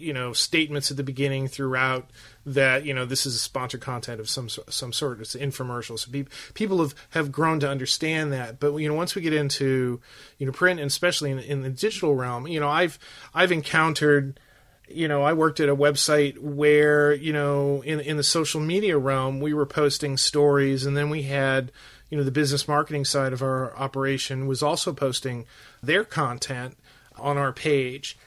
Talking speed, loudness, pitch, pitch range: 195 wpm, -24 LUFS, 140 Hz, 135-150 Hz